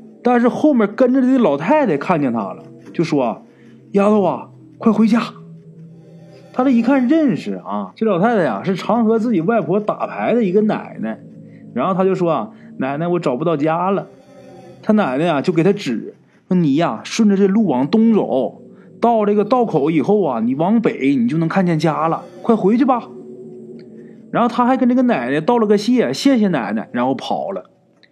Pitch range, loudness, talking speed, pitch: 180-235 Hz, -17 LUFS, 270 characters per minute, 215 Hz